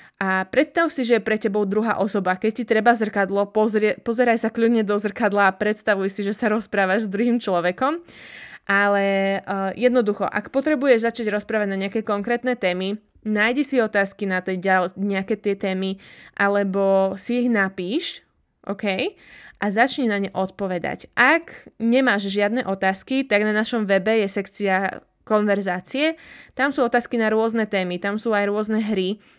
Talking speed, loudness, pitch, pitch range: 160 wpm, -21 LUFS, 210 Hz, 195-235 Hz